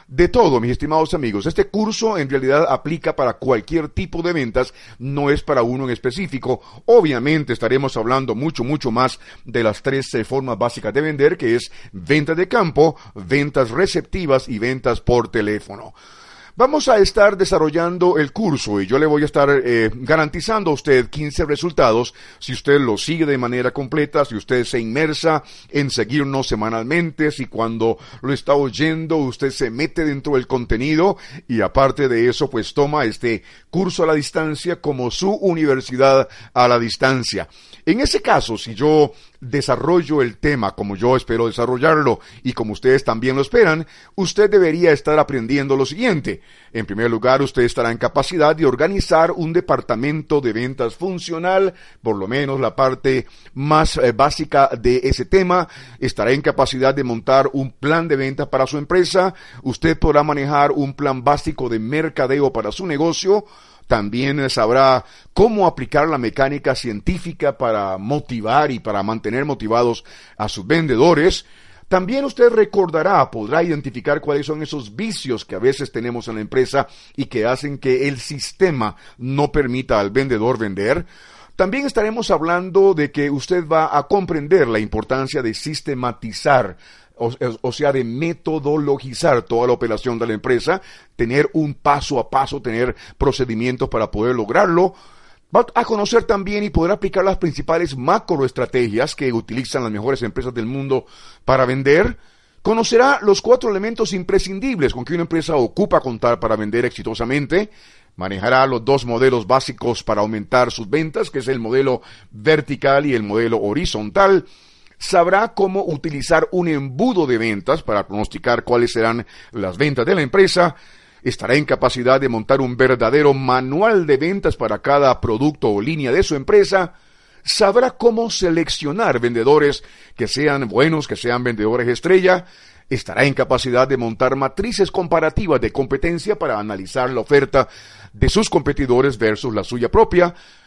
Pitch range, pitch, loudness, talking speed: 120-160 Hz, 140 Hz, -18 LUFS, 155 wpm